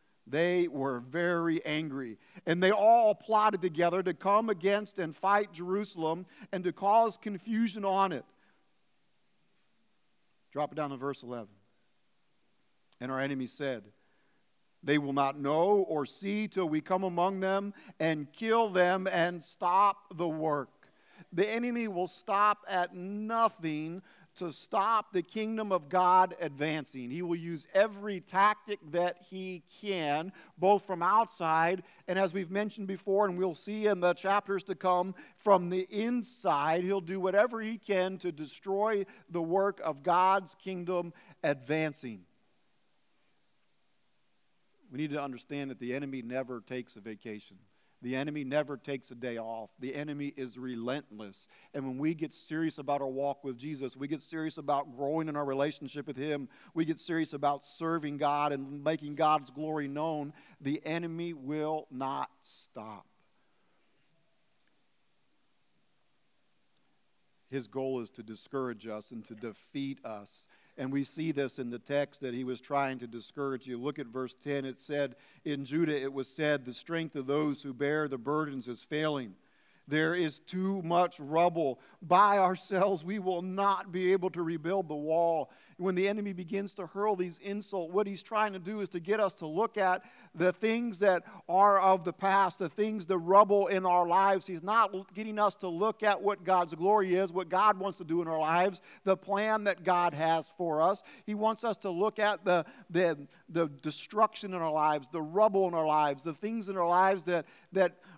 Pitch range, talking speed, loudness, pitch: 145-195 Hz, 170 wpm, -31 LUFS, 175 Hz